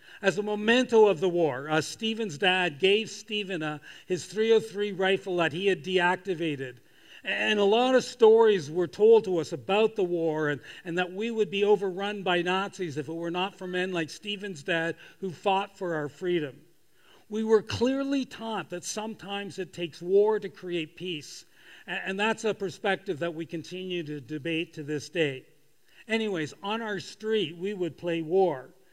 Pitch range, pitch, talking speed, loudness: 165-210 Hz, 185 Hz, 180 wpm, -28 LUFS